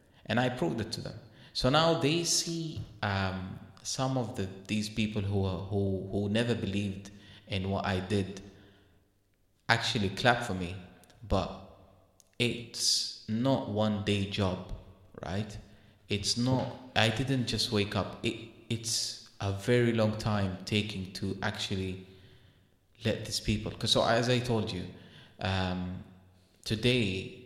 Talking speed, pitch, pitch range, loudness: 140 wpm, 105 Hz, 95-115 Hz, -31 LUFS